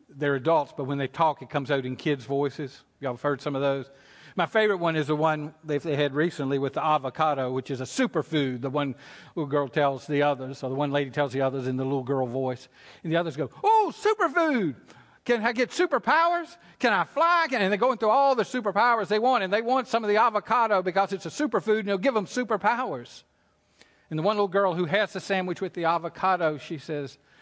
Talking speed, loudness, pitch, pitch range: 230 wpm, -26 LUFS, 160 Hz, 140-215 Hz